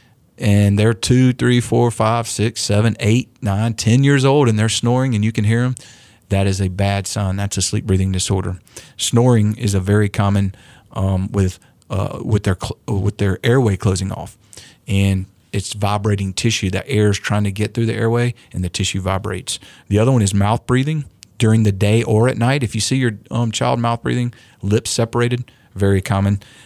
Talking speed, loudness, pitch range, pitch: 200 wpm, -18 LUFS, 100-120 Hz, 110 Hz